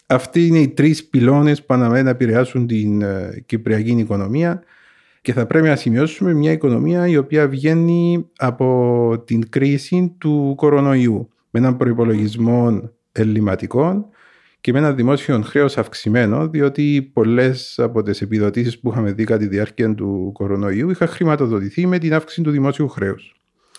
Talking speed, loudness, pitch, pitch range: 145 wpm, -17 LUFS, 130 Hz, 115-150 Hz